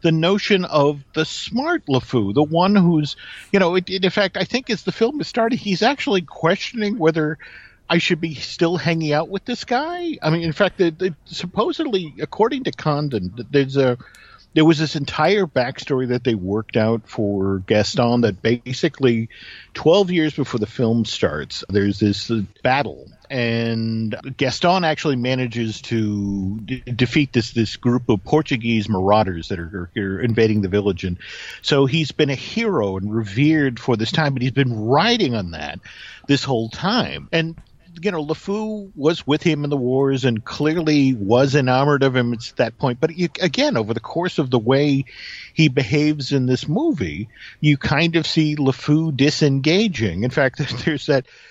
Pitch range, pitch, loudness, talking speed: 120-170 Hz, 145 Hz, -20 LUFS, 175 wpm